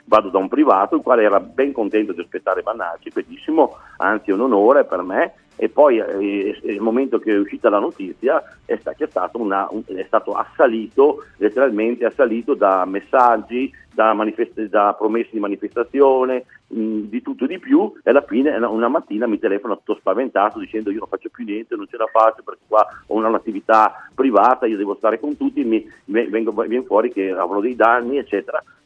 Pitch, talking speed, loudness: 120 Hz, 185 wpm, -18 LUFS